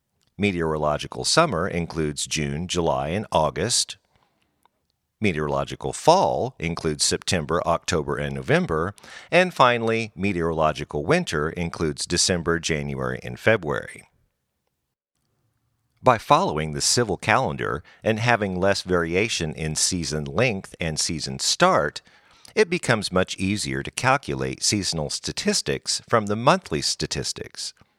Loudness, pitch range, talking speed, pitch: -23 LUFS, 75-105 Hz, 105 wpm, 85 Hz